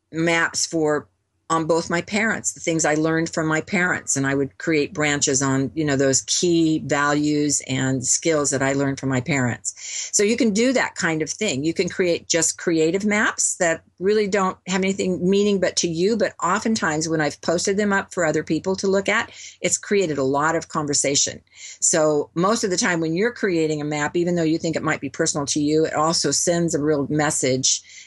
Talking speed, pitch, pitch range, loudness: 215 wpm, 160 Hz, 145-180 Hz, -21 LUFS